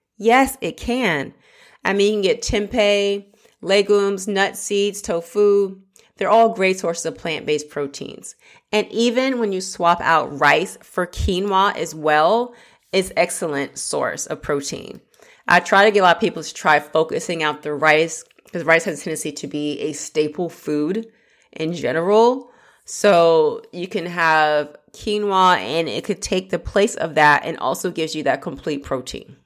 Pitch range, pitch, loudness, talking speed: 160-210 Hz, 190 Hz, -19 LUFS, 165 wpm